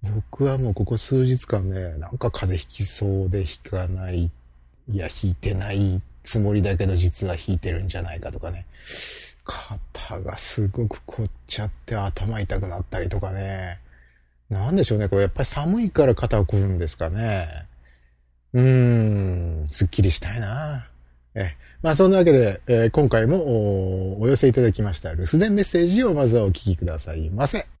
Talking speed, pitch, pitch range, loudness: 335 characters per minute, 100 Hz, 90-115 Hz, -23 LUFS